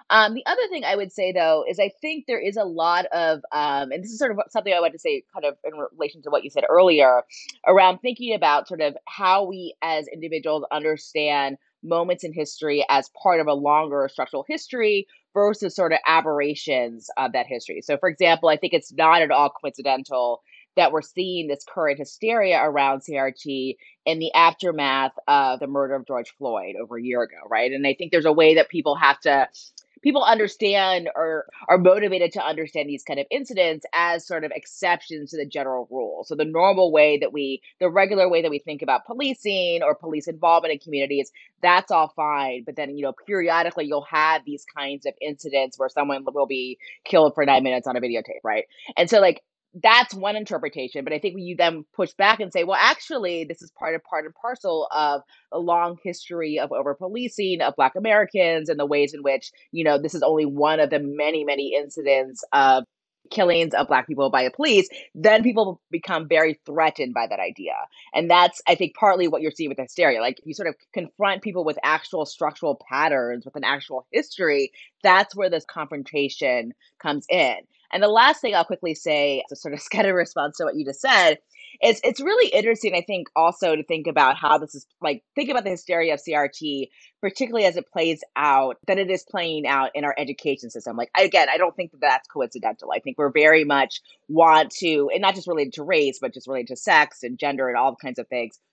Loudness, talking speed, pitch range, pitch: -21 LUFS, 215 wpm, 145-185 Hz, 160 Hz